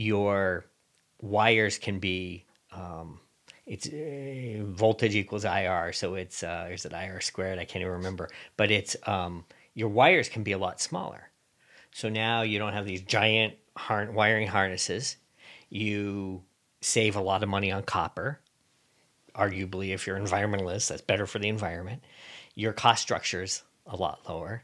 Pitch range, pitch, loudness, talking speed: 95-110 Hz, 100 Hz, -28 LUFS, 155 wpm